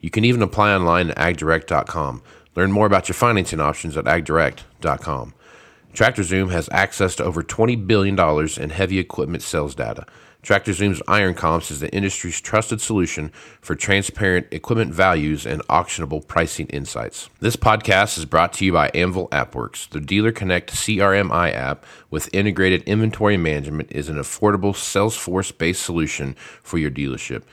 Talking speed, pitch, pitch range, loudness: 155 wpm, 90 Hz, 80-100 Hz, -20 LUFS